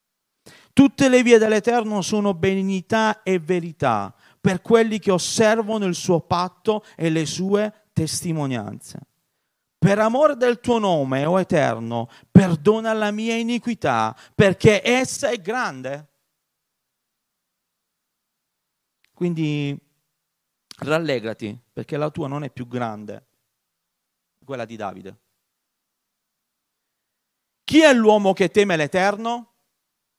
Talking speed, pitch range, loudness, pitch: 105 wpm, 145-220 Hz, -20 LUFS, 185 Hz